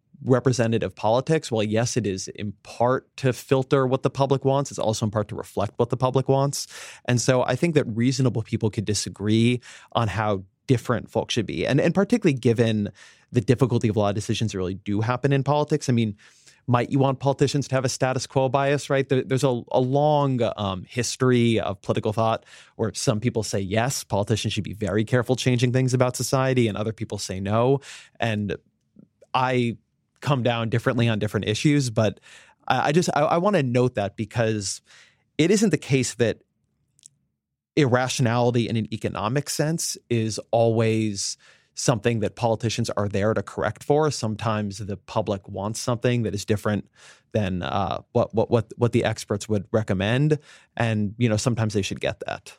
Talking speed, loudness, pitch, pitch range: 185 wpm, -24 LUFS, 120 Hz, 110-130 Hz